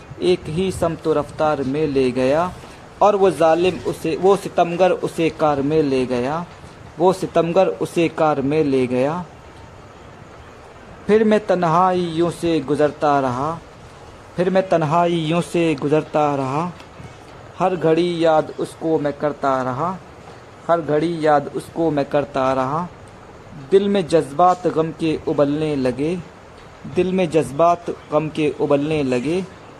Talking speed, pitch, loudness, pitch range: 135 wpm, 155 Hz, -19 LUFS, 145-170 Hz